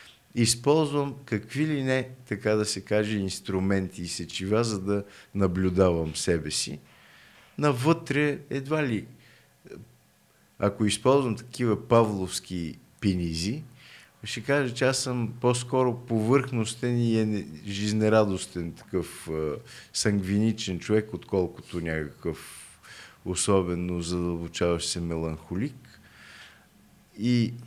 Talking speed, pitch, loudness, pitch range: 100 wpm, 105 Hz, -27 LUFS, 90-125 Hz